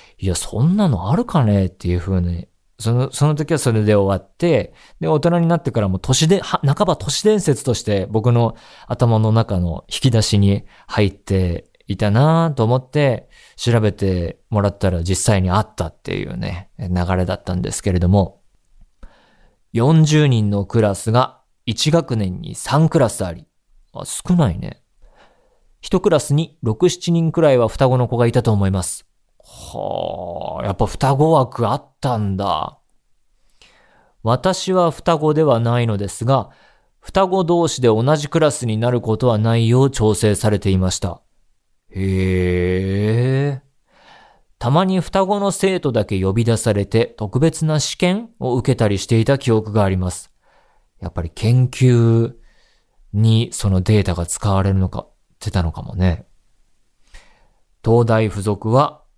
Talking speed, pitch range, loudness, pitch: 270 characters per minute, 100-145 Hz, -18 LUFS, 115 Hz